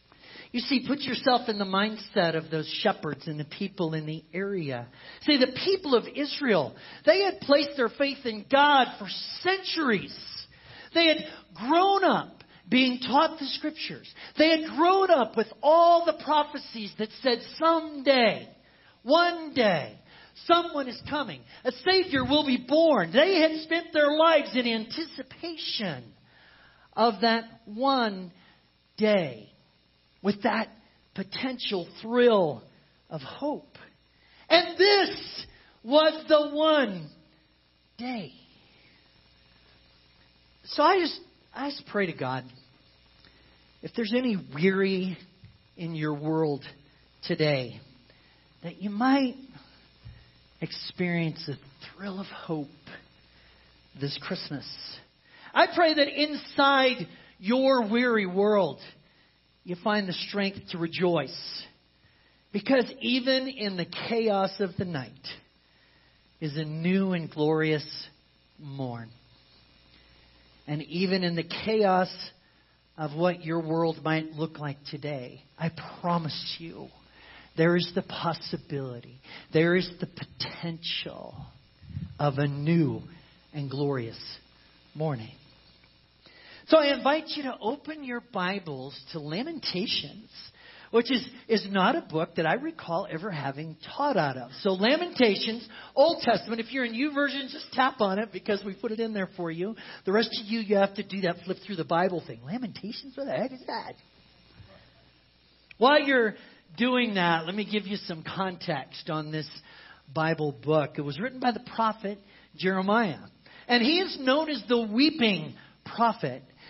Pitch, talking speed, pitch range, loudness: 195 Hz, 135 wpm, 155-255 Hz, -27 LUFS